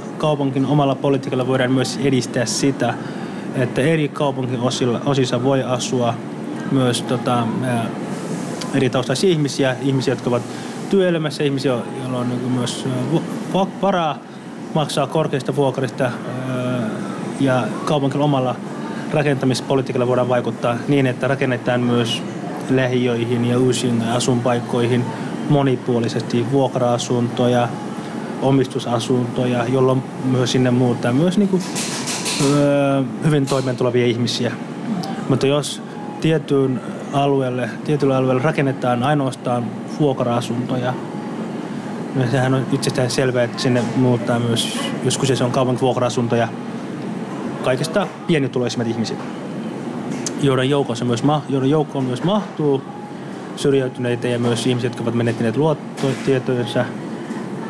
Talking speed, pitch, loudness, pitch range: 100 wpm, 130 Hz, -19 LUFS, 125-140 Hz